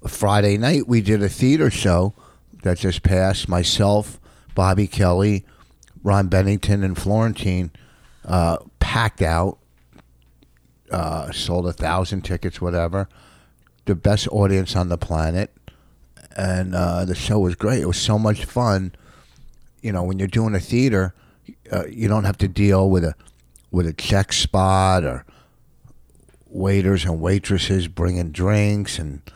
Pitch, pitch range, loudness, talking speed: 95 Hz, 85-100 Hz, -20 LUFS, 140 wpm